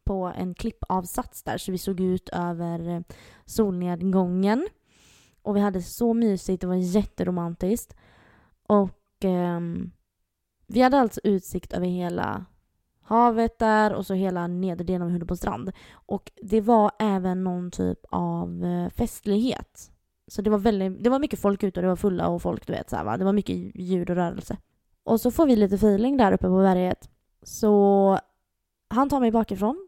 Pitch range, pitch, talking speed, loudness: 175-215 Hz, 190 Hz, 165 wpm, -25 LUFS